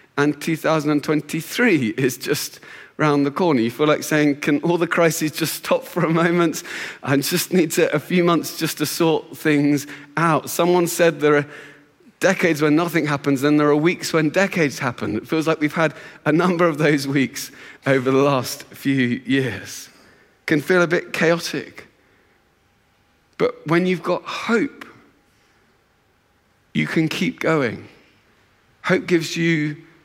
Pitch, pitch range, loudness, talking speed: 155 Hz, 145-170 Hz, -20 LUFS, 160 wpm